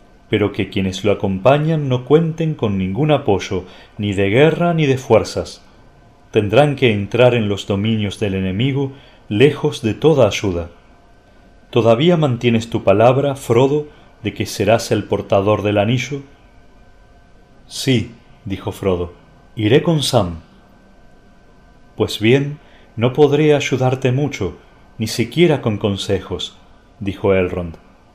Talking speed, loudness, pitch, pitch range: 125 wpm, -17 LUFS, 115 Hz, 100-140 Hz